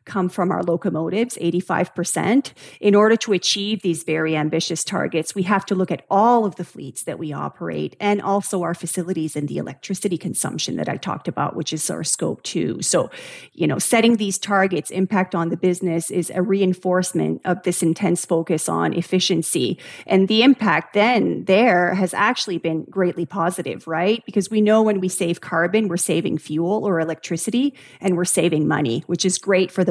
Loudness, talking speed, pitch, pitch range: -20 LUFS, 185 wpm, 180 Hz, 170-200 Hz